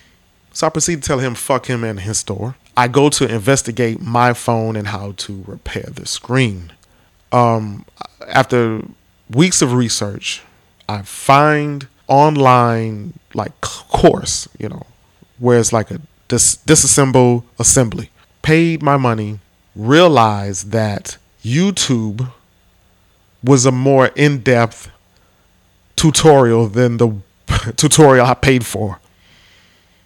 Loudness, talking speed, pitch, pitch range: -14 LUFS, 120 wpm, 115 Hz, 100-130 Hz